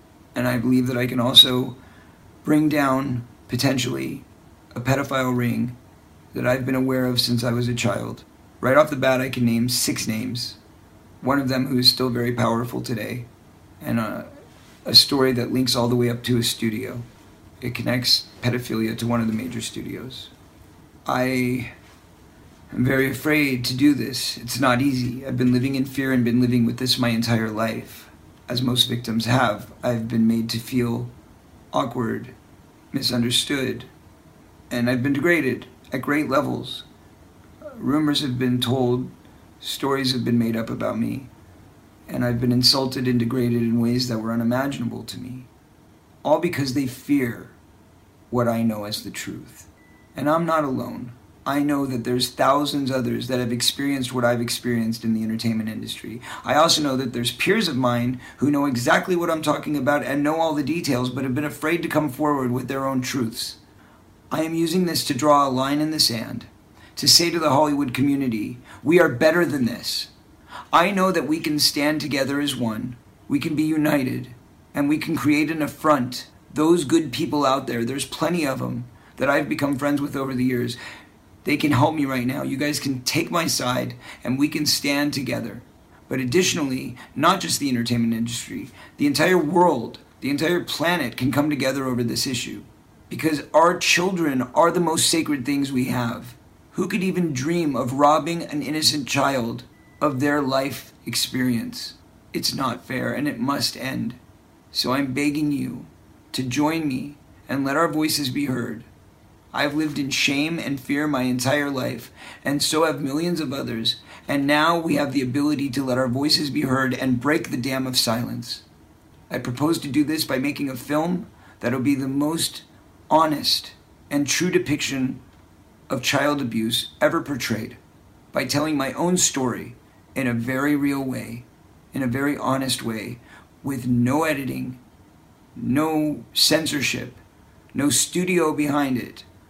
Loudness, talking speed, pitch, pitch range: -22 LUFS, 175 wpm, 130 Hz, 120-145 Hz